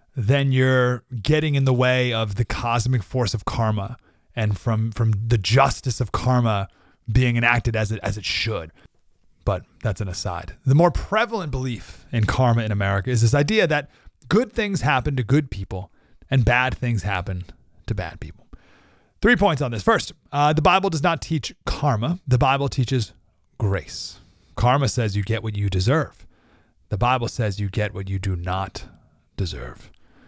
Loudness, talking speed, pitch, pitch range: -22 LUFS, 175 wpm, 115 Hz, 100-130 Hz